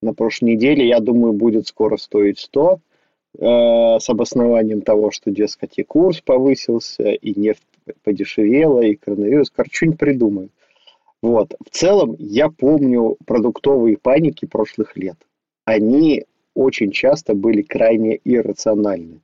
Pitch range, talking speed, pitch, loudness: 105-125 Hz, 130 wpm, 115 Hz, -16 LUFS